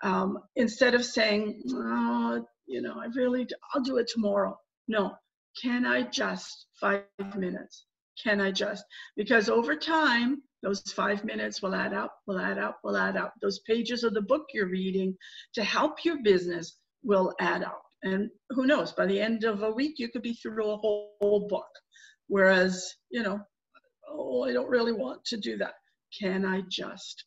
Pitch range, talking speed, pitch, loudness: 195-250 Hz, 185 wpm, 220 Hz, -29 LUFS